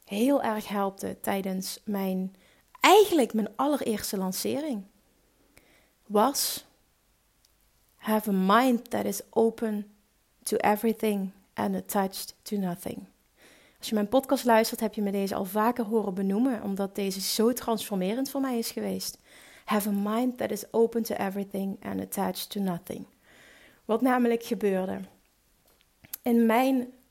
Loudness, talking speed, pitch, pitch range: -28 LUFS, 135 wpm, 215 Hz, 195-235 Hz